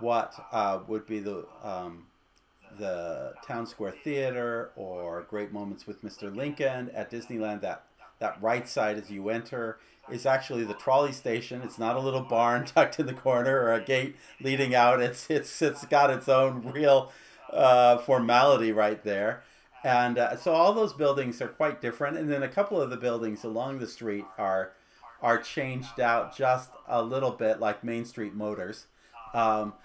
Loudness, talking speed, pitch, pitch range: -28 LUFS, 175 wpm, 120 Hz, 110-130 Hz